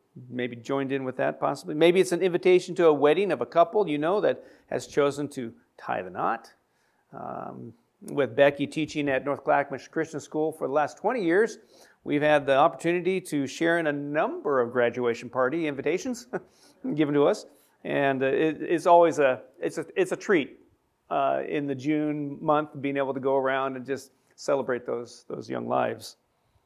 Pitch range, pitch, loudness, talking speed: 135-160 Hz, 145 Hz, -26 LUFS, 185 wpm